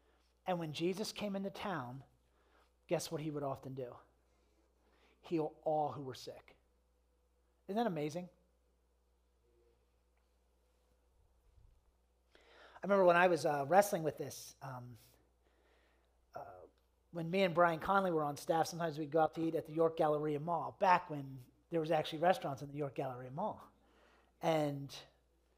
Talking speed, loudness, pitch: 145 wpm, -36 LUFS, 145 Hz